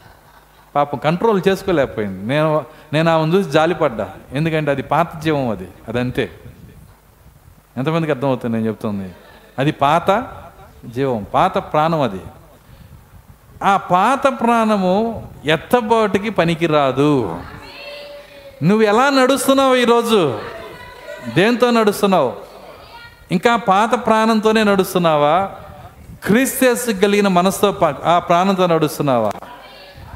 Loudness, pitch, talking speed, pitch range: -16 LUFS, 175 Hz, 90 wpm, 145-220 Hz